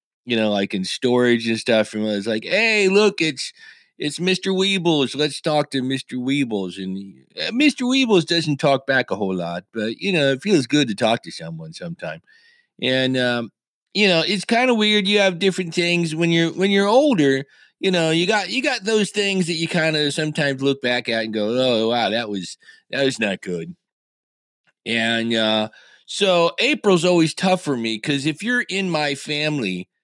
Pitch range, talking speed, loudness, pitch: 120-190 Hz, 200 wpm, -19 LUFS, 155 Hz